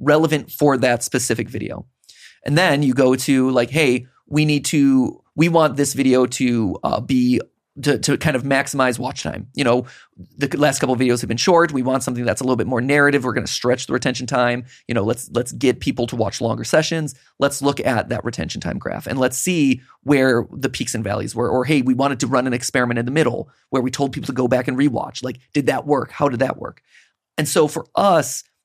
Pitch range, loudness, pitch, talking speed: 125-145 Hz, -19 LUFS, 130 Hz, 235 wpm